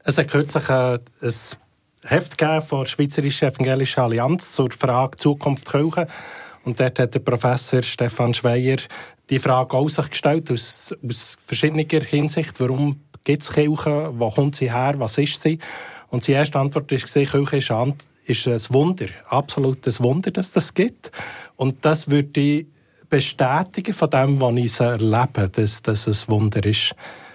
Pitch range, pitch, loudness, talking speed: 125-150 Hz, 135 Hz, -20 LUFS, 145 wpm